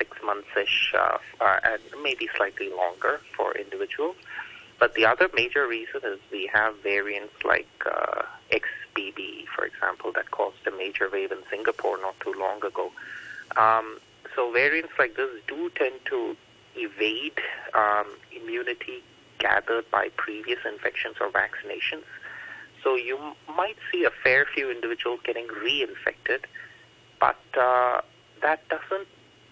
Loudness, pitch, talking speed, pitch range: -26 LUFS, 390 Hz, 140 wpm, 345-440 Hz